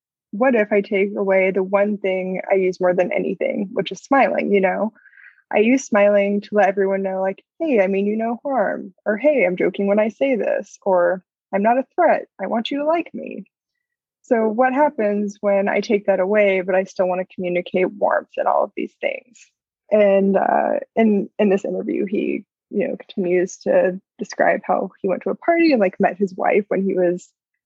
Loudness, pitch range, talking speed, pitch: -19 LUFS, 190-230 Hz, 210 wpm, 200 Hz